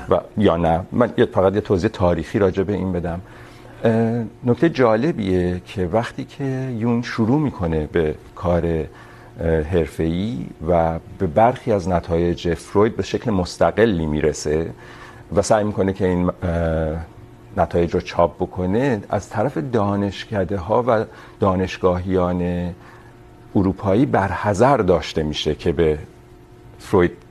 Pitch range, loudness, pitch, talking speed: 85-110 Hz, -20 LUFS, 95 Hz, 120 wpm